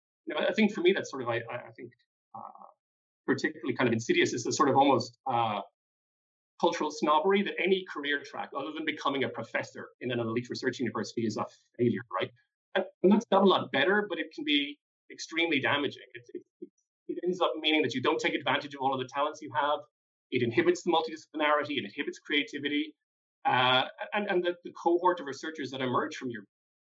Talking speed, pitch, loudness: 210 wpm, 175 Hz, -29 LUFS